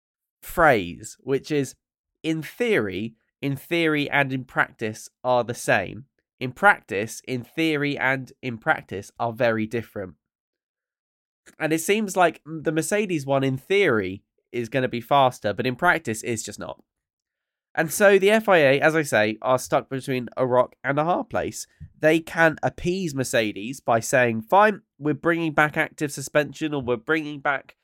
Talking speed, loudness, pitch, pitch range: 160 wpm, -23 LUFS, 140 Hz, 120-160 Hz